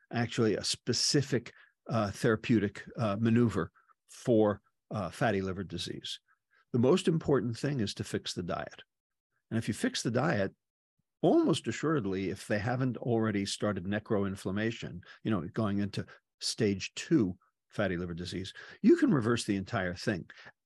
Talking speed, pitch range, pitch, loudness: 145 wpm, 100-120 Hz, 110 Hz, -31 LUFS